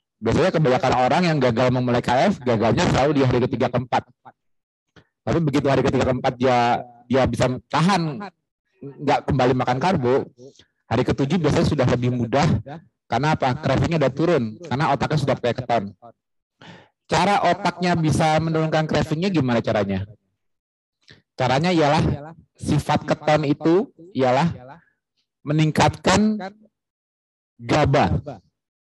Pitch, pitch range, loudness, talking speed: 135 Hz, 125-160 Hz, -20 LUFS, 120 wpm